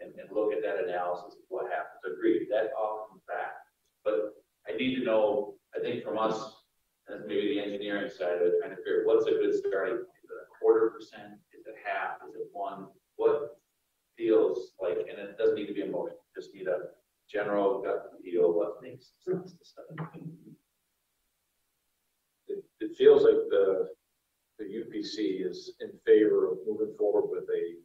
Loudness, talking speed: -30 LUFS, 185 wpm